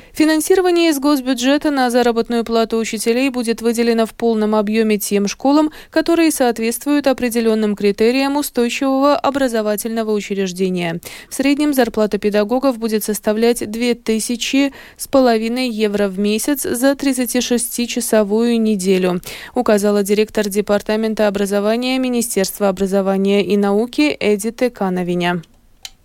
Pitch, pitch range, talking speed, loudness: 230 Hz, 210-255 Hz, 105 wpm, -16 LUFS